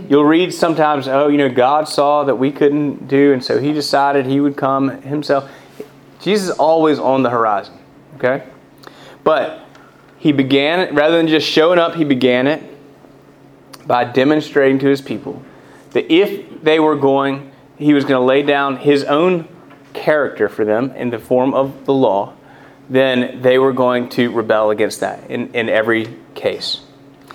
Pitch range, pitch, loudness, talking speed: 130-150 Hz, 140 Hz, -15 LUFS, 170 wpm